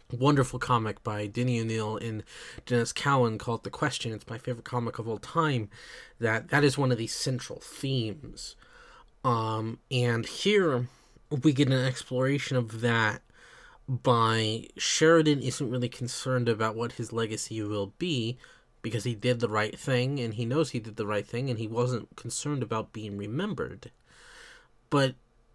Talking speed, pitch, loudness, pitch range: 160 wpm, 120 Hz, -29 LUFS, 115-130 Hz